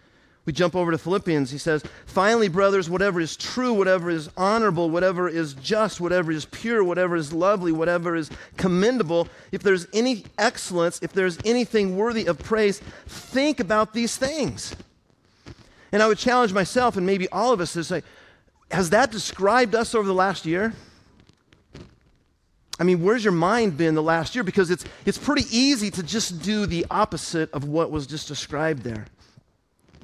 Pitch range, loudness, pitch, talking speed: 165-215 Hz, -23 LUFS, 185 Hz, 170 wpm